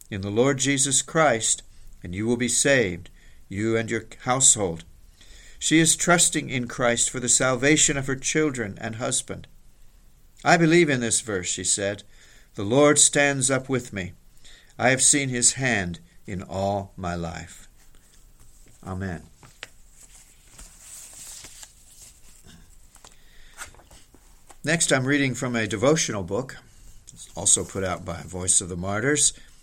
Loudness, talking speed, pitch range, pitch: -21 LUFS, 130 wpm, 90-135 Hz, 115 Hz